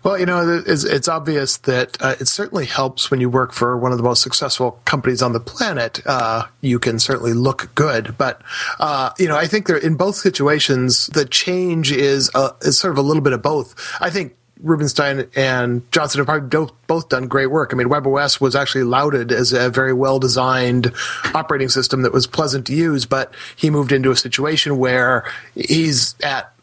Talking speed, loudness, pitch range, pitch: 195 wpm, -17 LUFS, 125-150 Hz, 135 Hz